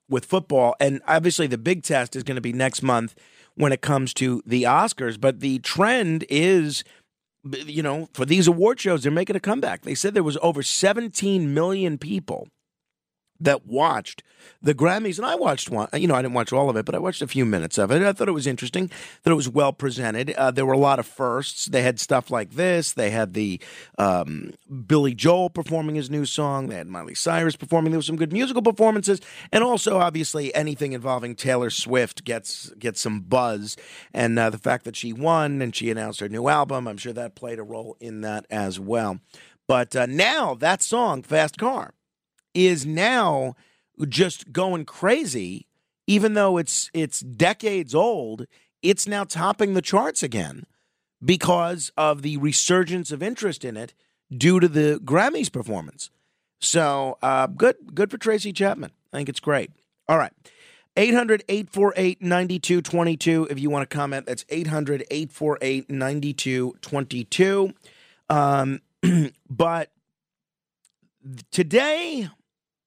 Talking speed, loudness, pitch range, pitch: 170 wpm, -22 LUFS, 130-180 Hz, 150 Hz